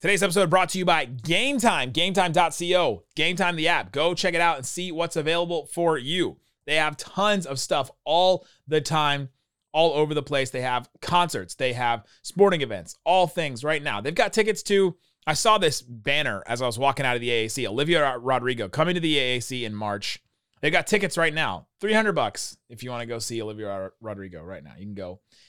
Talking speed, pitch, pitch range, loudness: 205 wpm, 150 Hz, 125-175 Hz, -24 LUFS